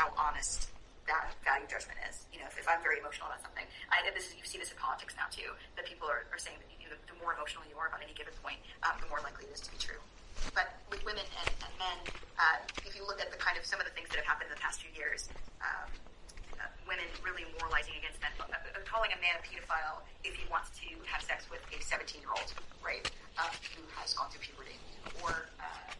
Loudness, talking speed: -38 LUFS, 260 wpm